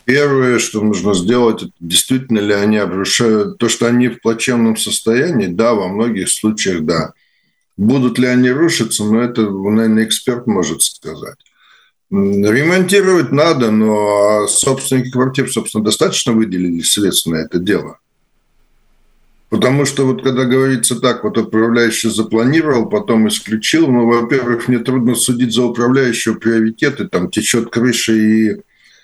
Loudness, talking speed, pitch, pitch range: -14 LUFS, 135 wpm, 115 Hz, 110-125 Hz